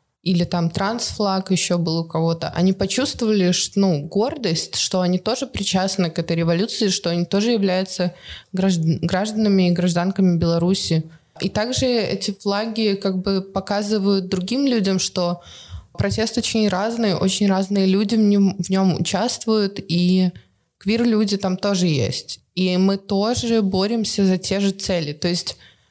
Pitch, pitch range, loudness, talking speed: 190 Hz, 175-205 Hz, -20 LUFS, 145 wpm